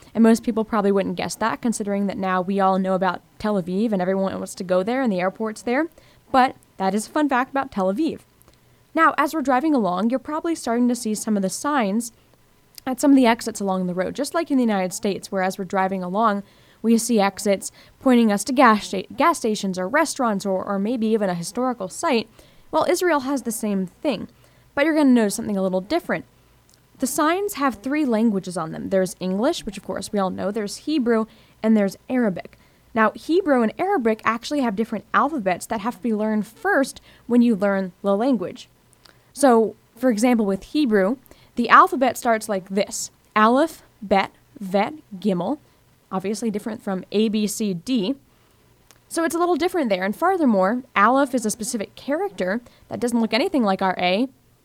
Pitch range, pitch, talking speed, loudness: 195-260 Hz, 220 Hz, 200 wpm, -22 LUFS